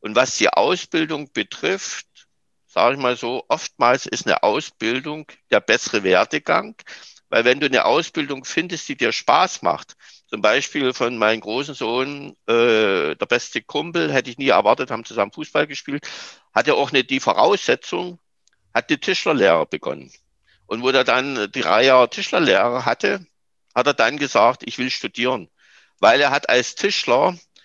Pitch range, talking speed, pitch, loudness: 125-165 Hz, 160 wpm, 140 Hz, -19 LUFS